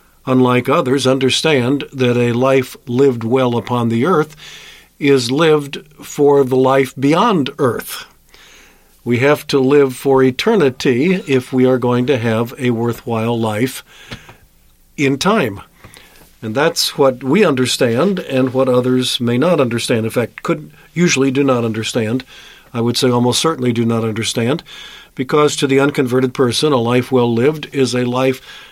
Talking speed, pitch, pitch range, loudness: 155 wpm, 130 Hz, 120-140 Hz, -15 LUFS